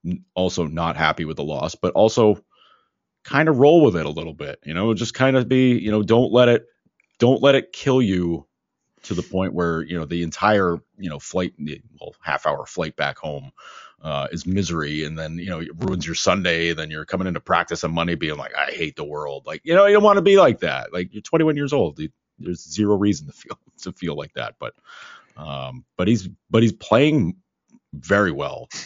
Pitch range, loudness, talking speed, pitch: 85-120 Hz, -20 LUFS, 220 wpm, 90 Hz